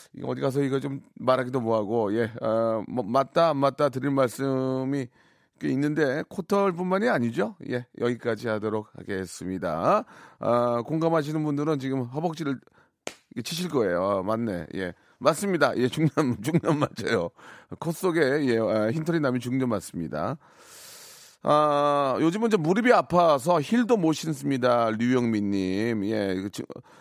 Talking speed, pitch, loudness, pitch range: 285 characters per minute, 135 Hz, -26 LUFS, 115-160 Hz